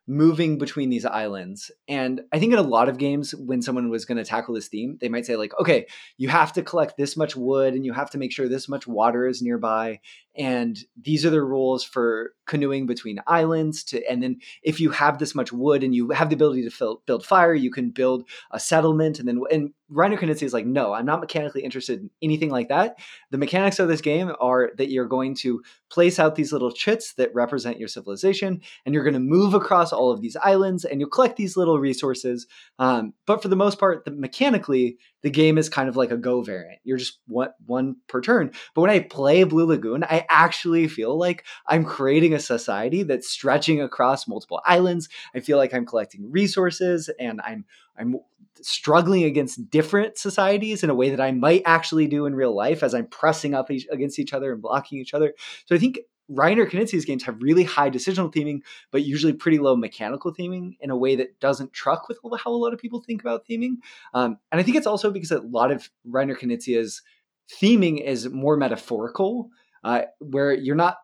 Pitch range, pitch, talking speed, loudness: 130-175 Hz, 145 Hz, 220 wpm, -22 LUFS